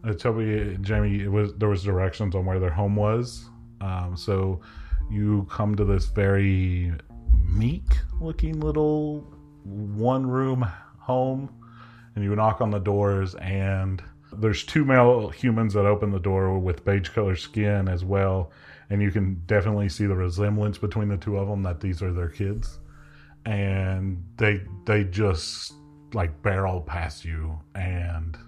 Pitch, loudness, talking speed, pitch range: 100 Hz, -25 LUFS, 150 wpm, 95-110 Hz